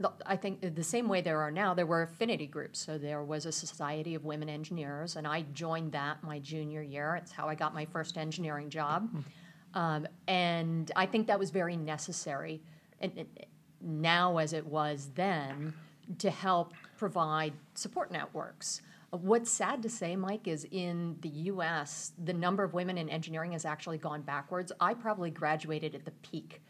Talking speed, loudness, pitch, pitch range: 180 wpm, -35 LUFS, 165 Hz, 155-180 Hz